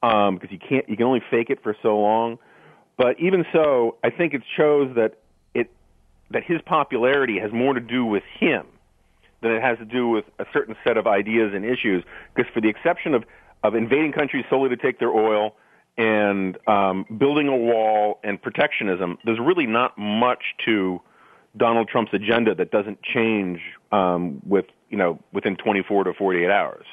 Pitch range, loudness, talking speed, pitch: 105-125 Hz, -22 LUFS, 185 wpm, 115 Hz